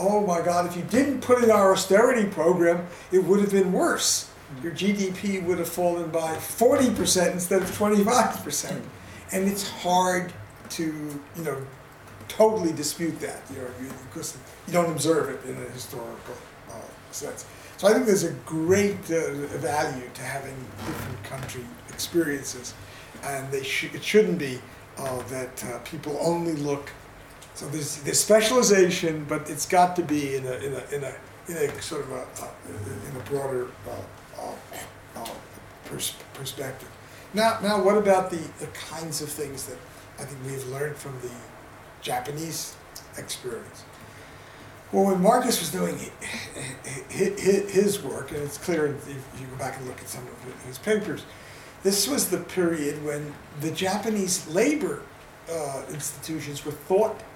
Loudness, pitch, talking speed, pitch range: -25 LUFS, 155 Hz, 155 wpm, 135-190 Hz